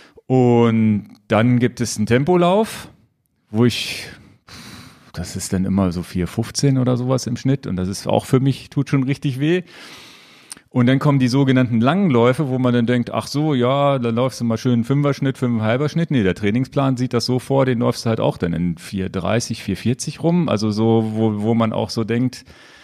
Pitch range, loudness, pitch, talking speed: 110-135 Hz, -19 LUFS, 125 Hz, 200 wpm